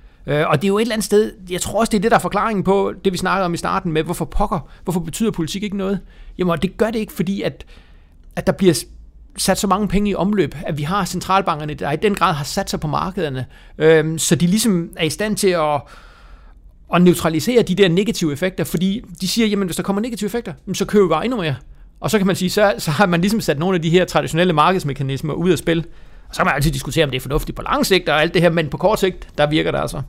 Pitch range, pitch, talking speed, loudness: 160-195 Hz, 180 Hz, 275 wpm, -18 LUFS